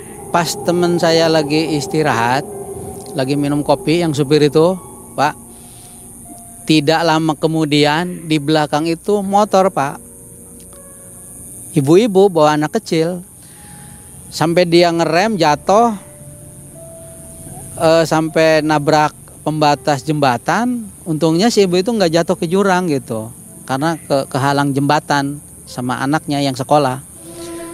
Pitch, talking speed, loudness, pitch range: 155 Hz, 110 wpm, -15 LUFS, 145-175 Hz